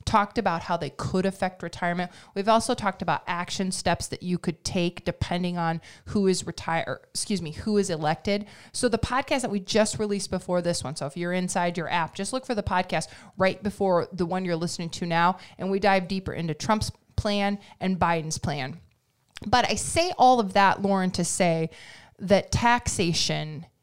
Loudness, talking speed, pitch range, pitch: -26 LUFS, 195 wpm, 170-200 Hz, 180 Hz